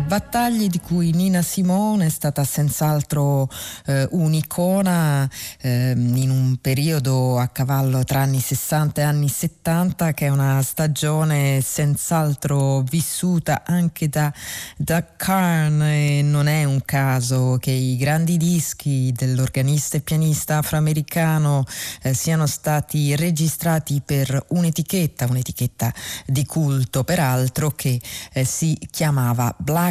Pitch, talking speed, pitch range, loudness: 145 Hz, 120 wpm, 135-160 Hz, -20 LUFS